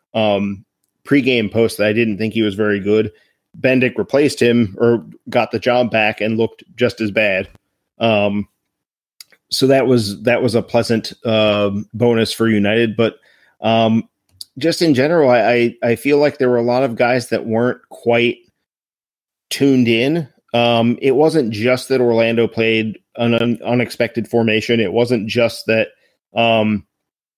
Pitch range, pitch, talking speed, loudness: 110-120 Hz, 115 Hz, 160 wpm, -16 LUFS